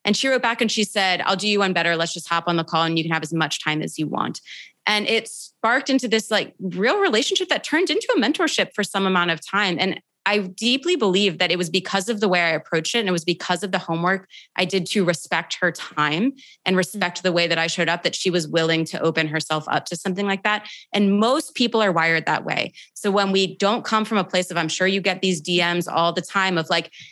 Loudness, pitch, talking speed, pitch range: -21 LUFS, 190 Hz, 265 wpm, 170-210 Hz